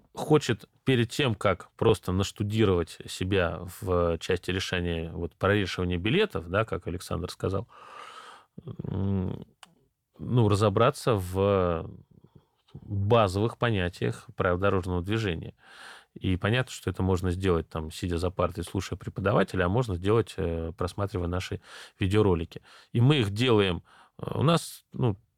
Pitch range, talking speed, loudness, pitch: 90-110 Hz, 120 wpm, -28 LUFS, 95 Hz